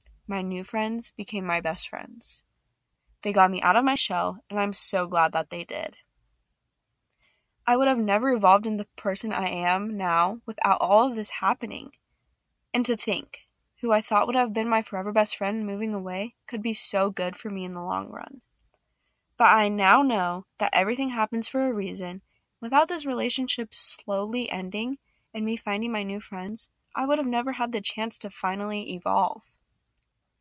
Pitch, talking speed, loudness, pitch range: 210 Hz, 185 wpm, -25 LUFS, 185-230 Hz